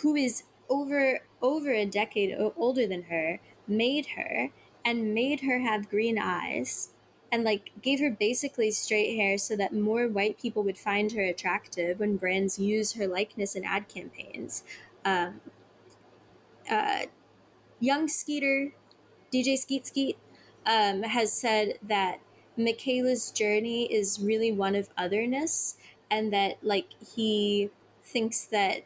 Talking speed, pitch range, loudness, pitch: 135 wpm, 205-255 Hz, -28 LUFS, 215 Hz